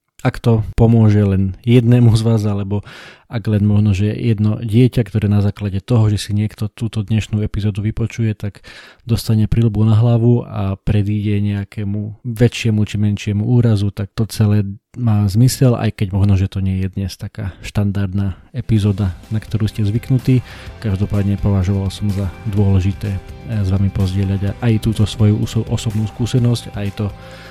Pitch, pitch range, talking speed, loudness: 105 Hz, 100-115 Hz, 155 wpm, -17 LUFS